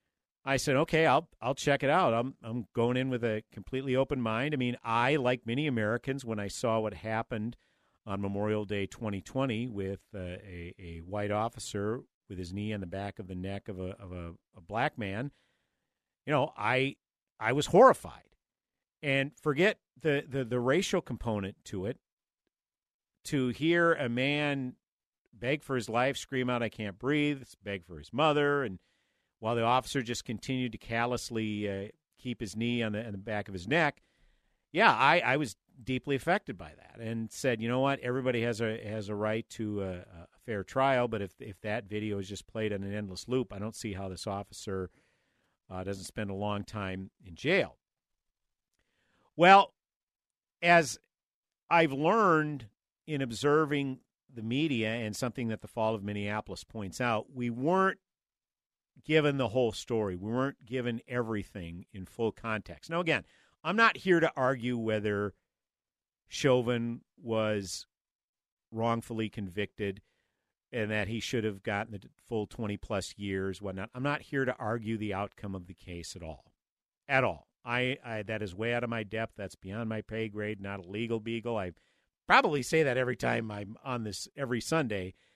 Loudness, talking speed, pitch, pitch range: -31 LUFS, 180 wpm, 115 Hz, 100-130 Hz